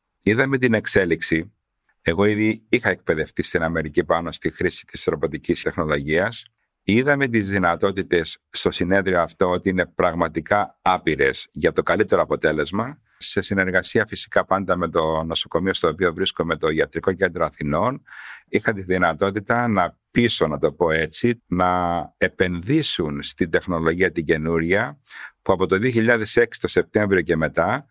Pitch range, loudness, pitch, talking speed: 85-110 Hz, -21 LUFS, 95 Hz, 140 wpm